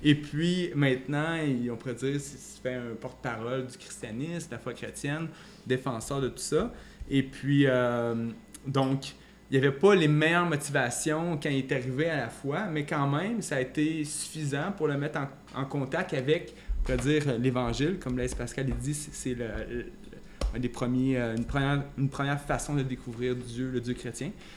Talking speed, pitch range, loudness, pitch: 185 wpm, 125-150 Hz, -30 LUFS, 135 Hz